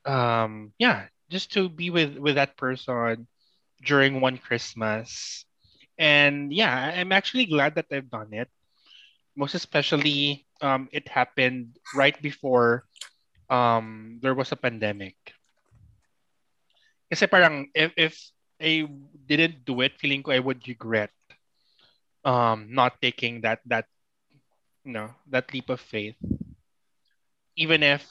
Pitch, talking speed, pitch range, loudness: 130 Hz, 120 wpm, 120-150 Hz, -24 LUFS